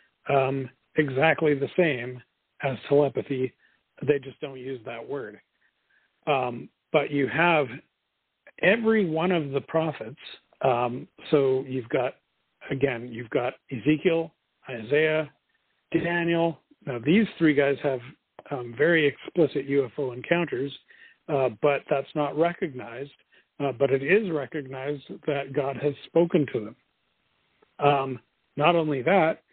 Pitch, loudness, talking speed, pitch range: 145 Hz, -26 LUFS, 125 wpm, 135-160 Hz